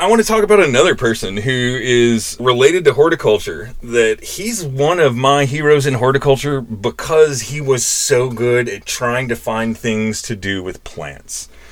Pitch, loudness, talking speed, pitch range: 130 Hz, -15 LUFS, 175 wpm, 115-160 Hz